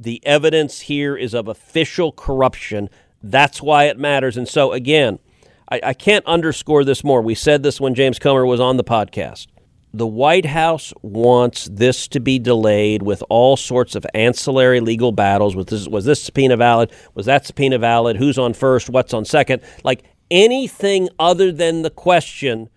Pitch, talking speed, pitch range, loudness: 130 Hz, 175 wpm, 115-150 Hz, -16 LUFS